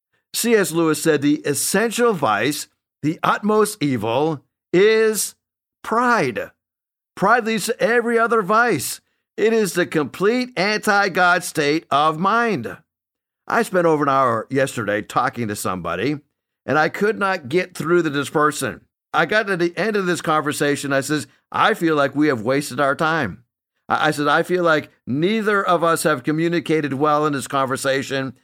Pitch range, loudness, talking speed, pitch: 140-195 Hz, -19 LUFS, 160 wpm, 155 Hz